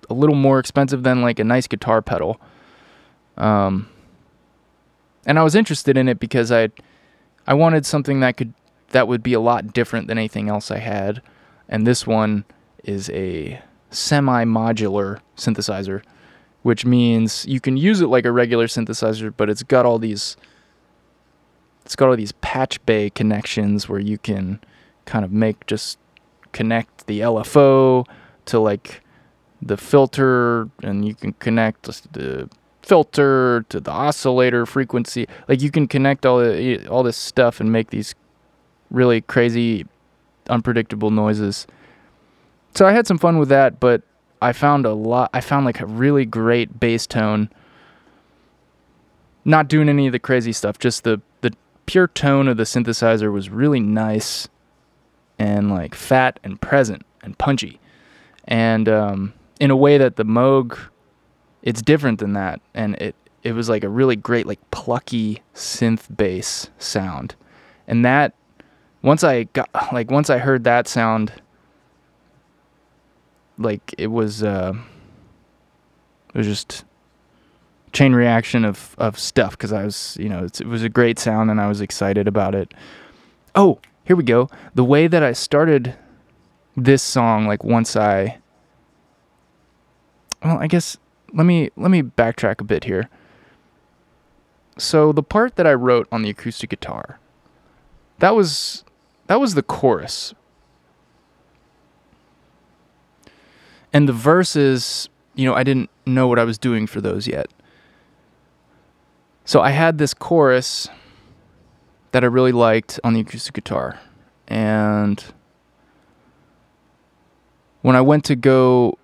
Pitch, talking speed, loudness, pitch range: 115 Hz, 145 wpm, -18 LUFS, 105-130 Hz